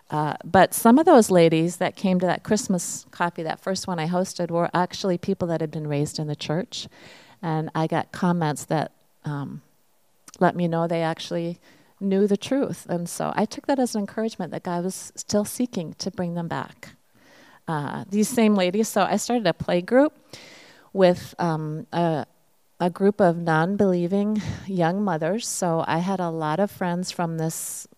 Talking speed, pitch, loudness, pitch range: 185 wpm, 180 Hz, -24 LUFS, 165-200 Hz